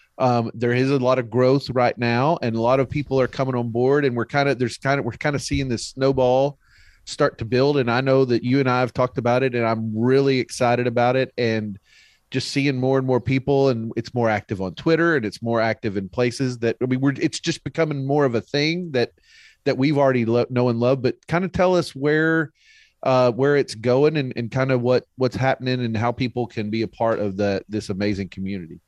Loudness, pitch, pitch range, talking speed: -21 LUFS, 125 Hz, 120-140 Hz, 245 wpm